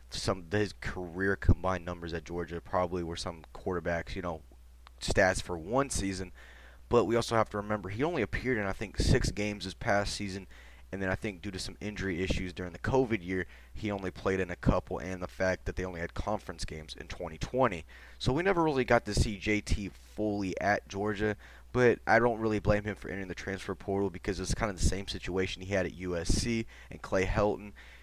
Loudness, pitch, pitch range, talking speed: -32 LUFS, 95 Hz, 90-105 Hz, 215 wpm